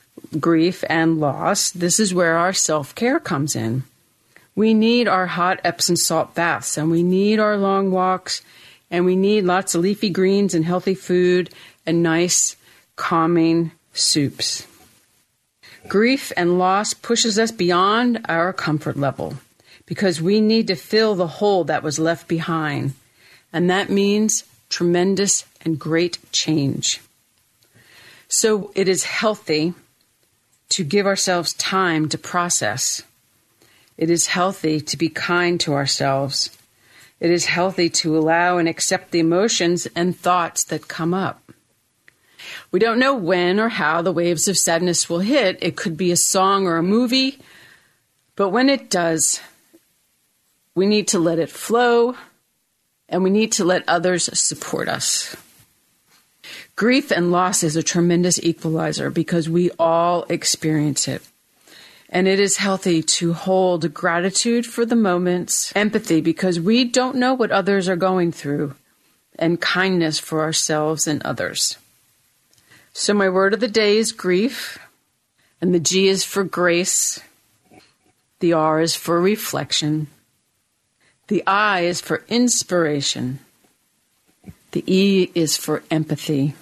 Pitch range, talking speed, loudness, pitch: 160-195 Hz, 140 wpm, -19 LUFS, 175 Hz